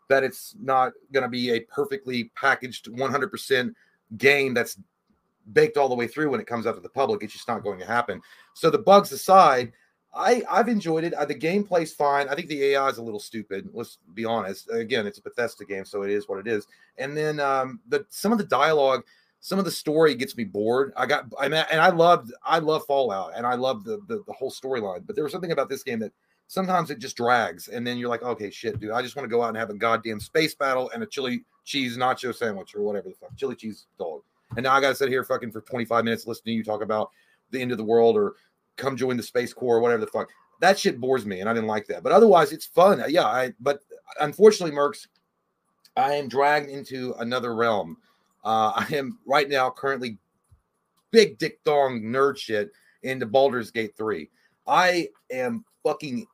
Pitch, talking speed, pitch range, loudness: 135 Hz, 230 wpm, 115-160 Hz, -24 LUFS